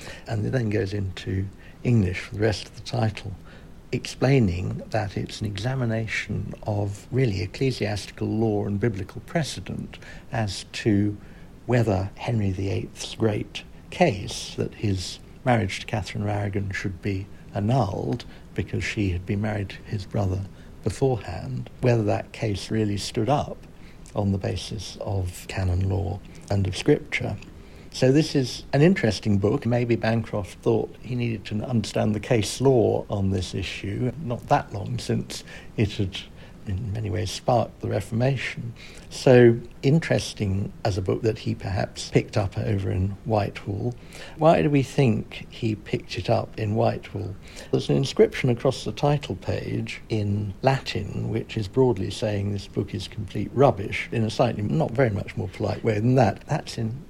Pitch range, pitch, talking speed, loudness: 100-120 Hz, 105 Hz, 155 wpm, -25 LUFS